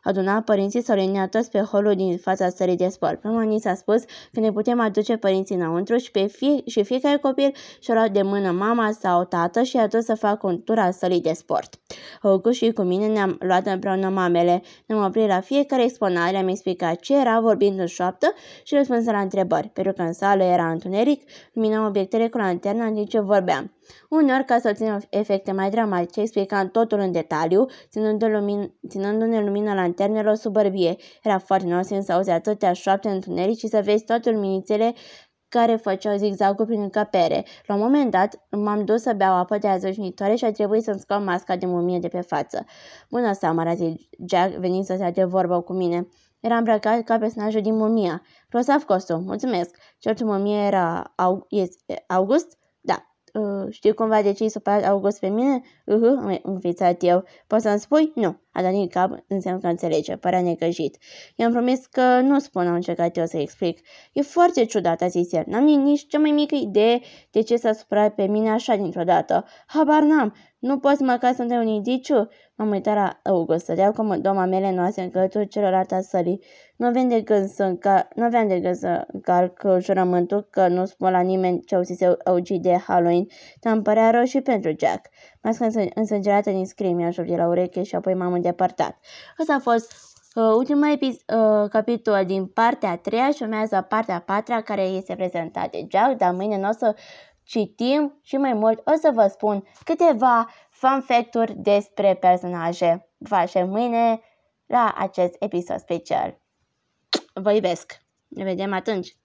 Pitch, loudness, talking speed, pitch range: 205 Hz, -22 LUFS, 185 wpm, 185-230 Hz